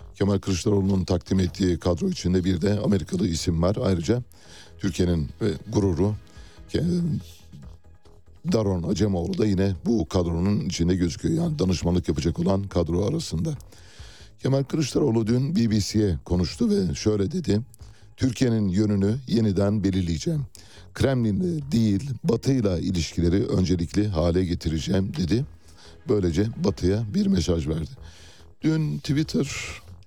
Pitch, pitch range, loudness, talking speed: 95 Hz, 85-110 Hz, -24 LUFS, 110 wpm